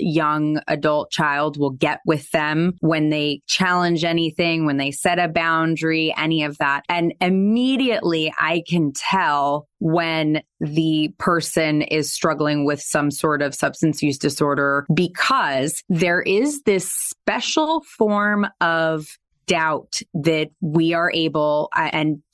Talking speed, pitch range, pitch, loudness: 135 wpm, 150-175 Hz, 160 Hz, -20 LUFS